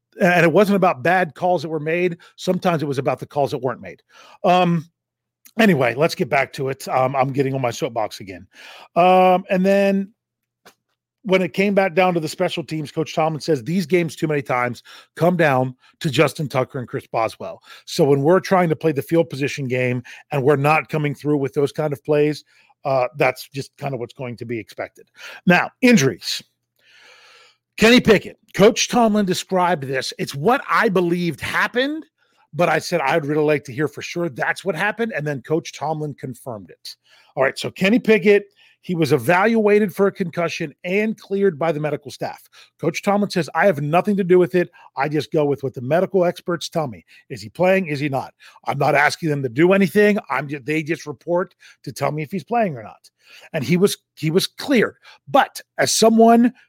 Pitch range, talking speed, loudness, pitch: 140-190 Hz, 205 wpm, -19 LUFS, 165 Hz